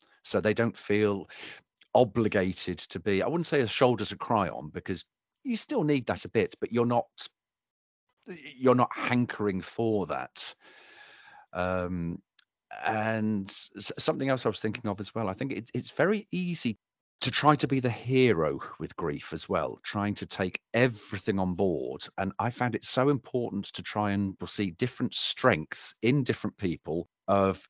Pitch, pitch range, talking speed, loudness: 110 Hz, 100-130 Hz, 170 wpm, -29 LUFS